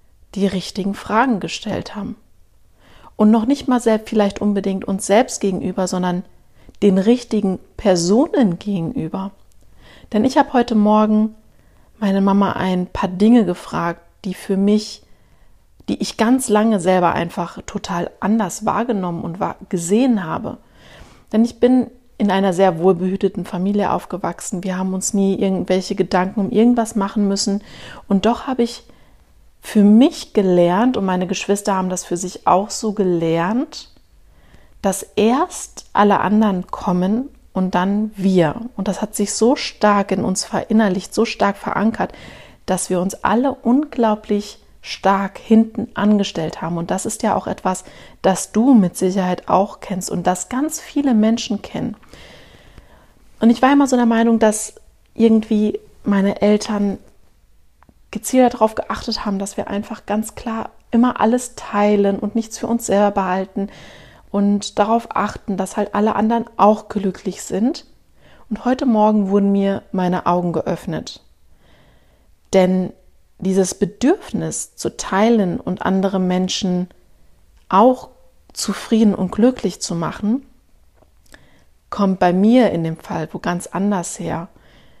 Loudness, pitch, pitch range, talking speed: -18 LUFS, 205 Hz, 190-225 Hz, 140 wpm